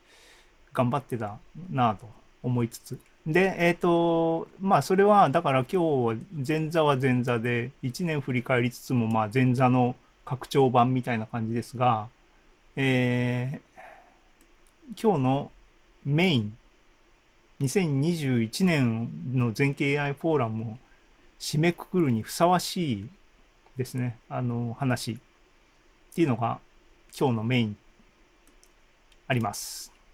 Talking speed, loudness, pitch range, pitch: 215 characters per minute, -26 LUFS, 120-155 Hz, 130 Hz